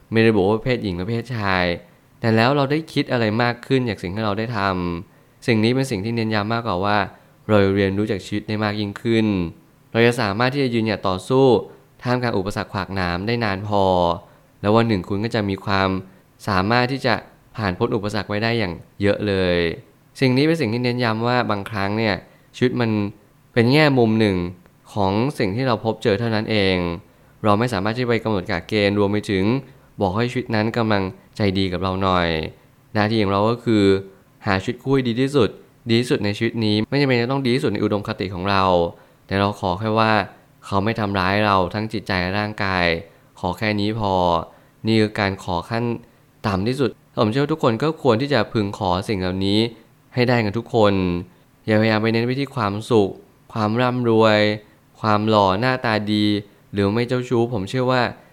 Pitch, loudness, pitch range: 110 Hz, -20 LUFS, 100-125 Hz